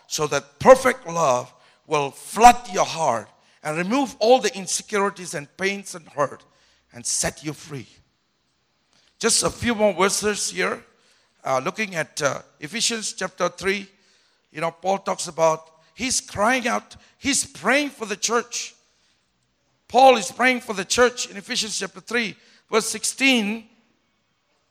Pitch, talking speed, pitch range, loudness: 195 Hz, 145 wpm, 155-230 Hz, -21 LUFS